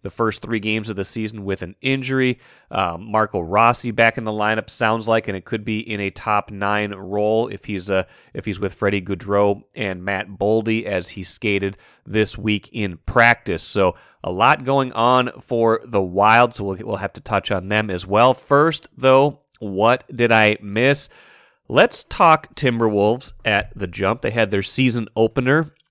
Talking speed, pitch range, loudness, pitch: 190 wpm, 100-120 Hz, -19 LUFS, 110 Hz